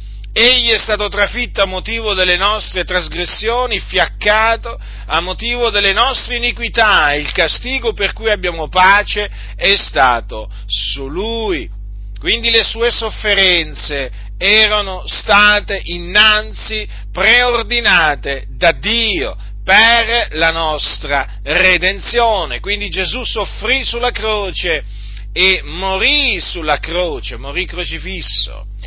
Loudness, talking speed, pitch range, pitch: -13 LUFS, 105 wpm, 165-225 Hz, 200 Hz